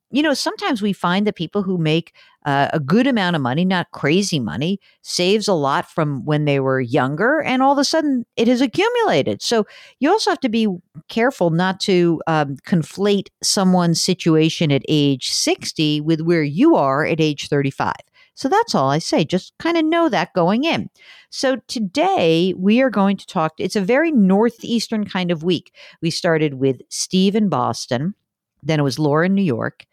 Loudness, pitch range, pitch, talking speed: -18 LUFS, 160-230 Hz, 185 Hz, 195 wpm